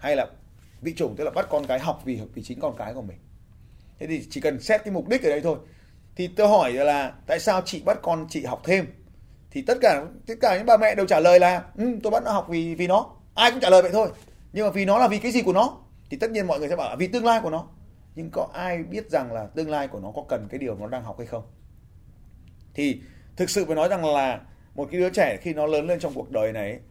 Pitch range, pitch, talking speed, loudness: 130-205 Hz, 165 Hz, 285 wpm, -23 LUFS